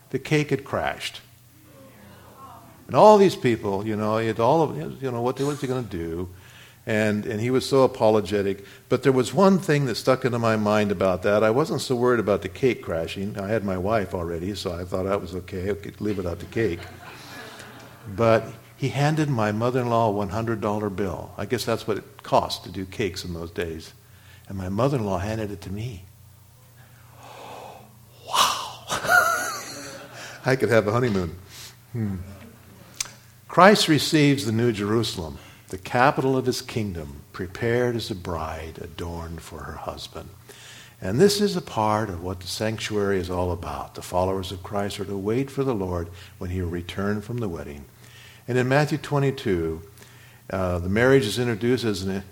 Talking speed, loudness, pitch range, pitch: 185 wpm, -24 LUFS, 95-125 Hz, 110 Hz